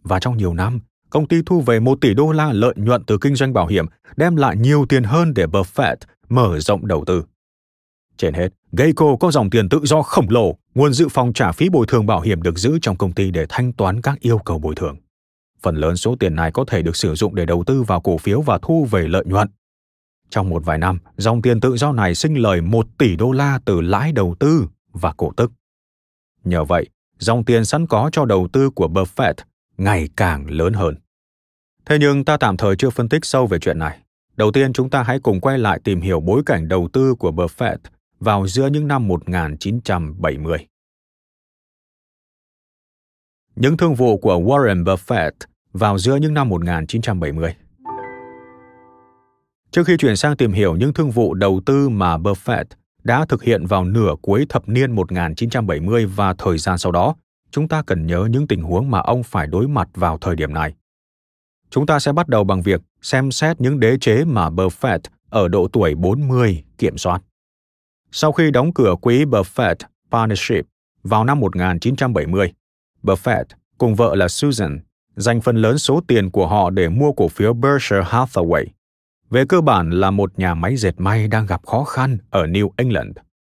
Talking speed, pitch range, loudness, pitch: 195 wpm, 90-130 Hz, -17 LUFS, 105 Hz